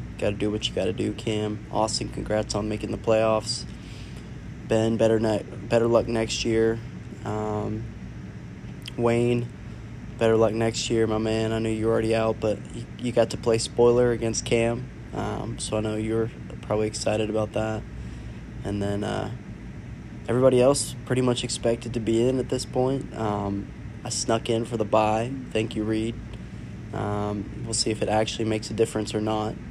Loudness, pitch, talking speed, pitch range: -25 LUFS, 110 Hz, 180 wpm, 110-115 Hz